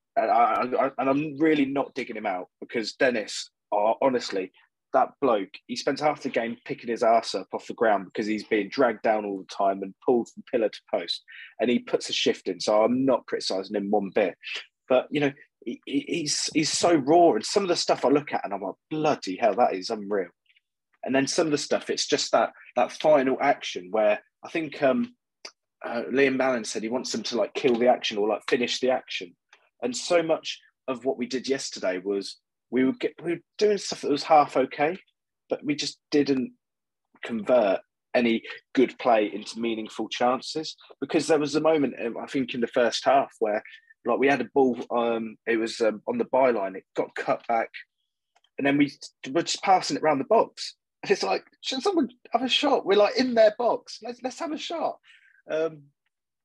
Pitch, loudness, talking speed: 145 Hz, -25 LUFS, 210 wpm